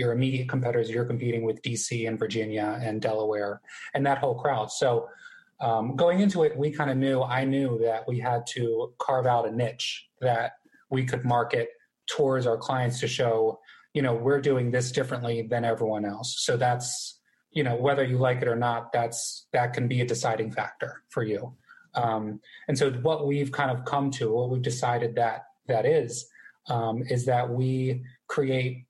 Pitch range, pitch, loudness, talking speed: 115-135 Hz, 125 Hz, -27 LUFS, 190 wpm